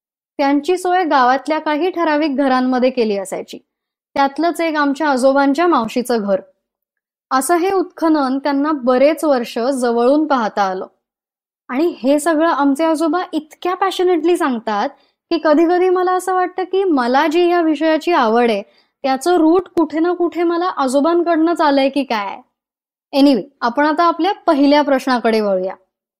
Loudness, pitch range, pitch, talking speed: -16 LUFS, 260-340 Hz, 300 Hz, 140 wpm